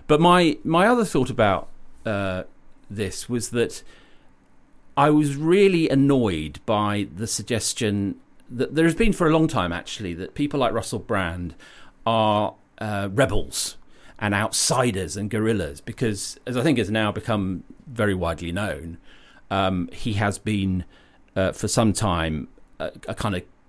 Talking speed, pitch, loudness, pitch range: 150 wpm, 110 Hz, -23 LUFS, 95-130 Hz